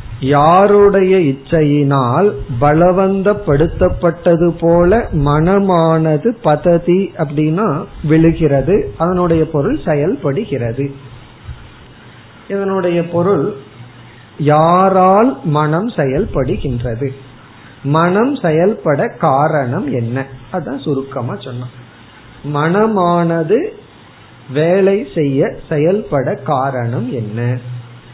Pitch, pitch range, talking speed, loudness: 155 Hz, 135-180 Hz, 60 wpm, -14 LUFS